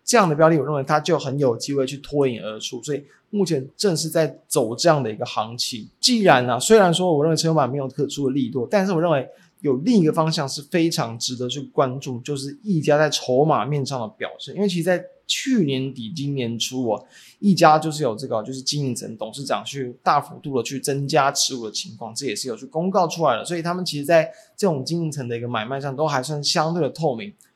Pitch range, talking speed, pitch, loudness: 130-165 Hz, 350 characters per minute, 145 Hz, -21 LUFS